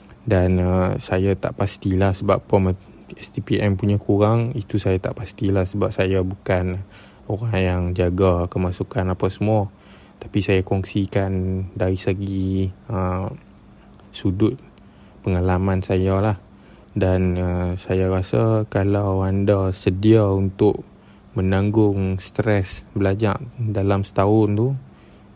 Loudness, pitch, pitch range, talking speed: -21 LUFS, 95 Hz, 95-105 Hz, 110 wpm